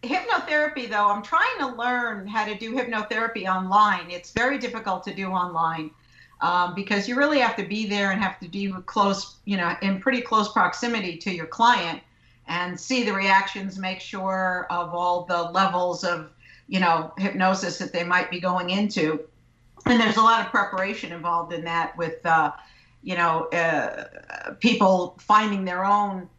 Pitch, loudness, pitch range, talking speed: 195 Hz, -24 LUFS, 175-220 Hz, 175 wpm